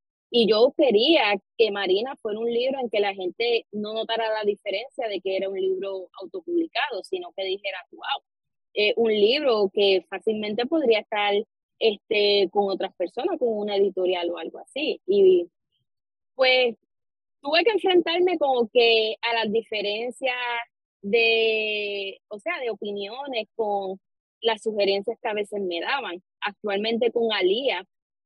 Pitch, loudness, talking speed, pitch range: 225 Hz, -24 LUFS, 145 wpm, 200-270 Hz